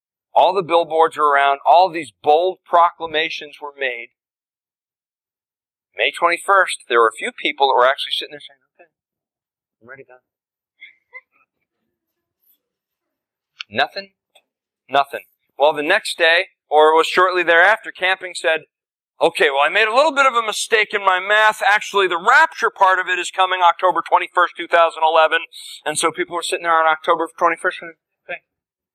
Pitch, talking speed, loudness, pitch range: 170 Hz, 155 wpm, -16 LUFS, 160-190 Hz